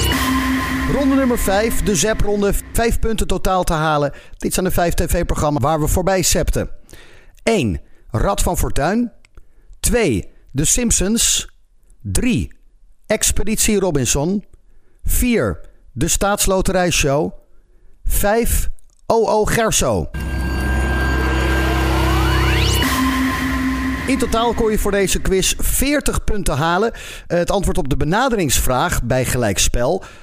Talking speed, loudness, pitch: 105 wpm, -18 LUFS, 190 Hz